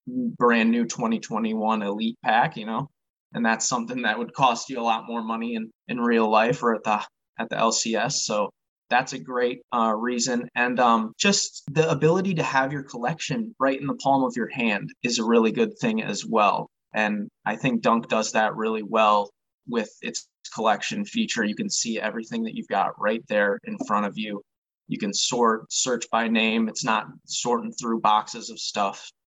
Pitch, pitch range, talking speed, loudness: 120 Hz, 110-160 Hz, 195 wpm, -24 LUFS